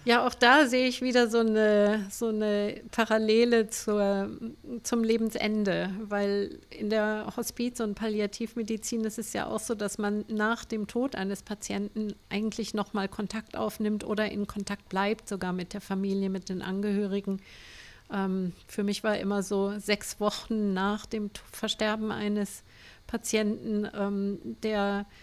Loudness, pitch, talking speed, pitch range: -29 LUFS, 210 Hz, 150 wpm, 200-225 Hz